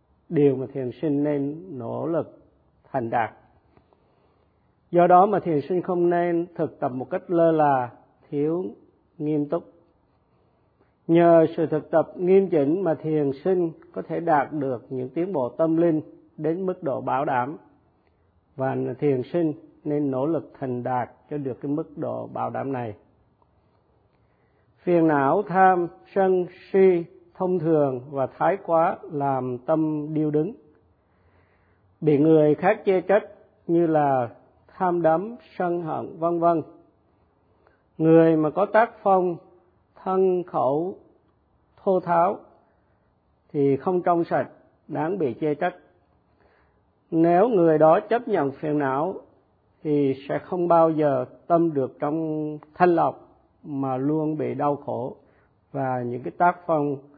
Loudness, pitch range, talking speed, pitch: -23 LUFS, 135-175 Hz, 140 wpm, 155 Hz